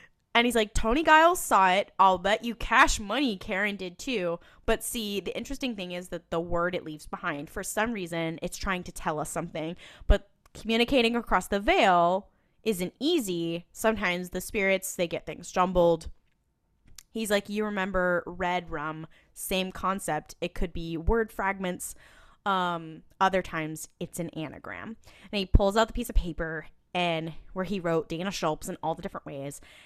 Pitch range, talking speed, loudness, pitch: 165-210 Hz, 175 wpm, -28 LUFS, 180 Hz